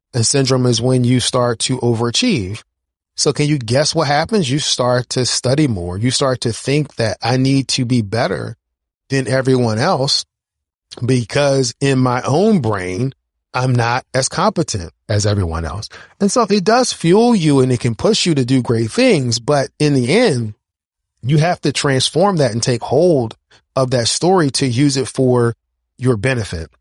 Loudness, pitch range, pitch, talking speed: -16 LUFS, 115-145 Hz, 125 Hz, 180 wpm